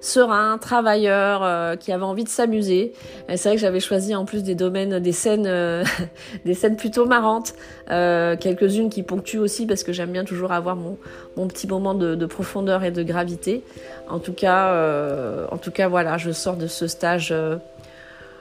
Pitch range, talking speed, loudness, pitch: 175-205 Hz, 195 wpm, -22 LUFS, 185 Hz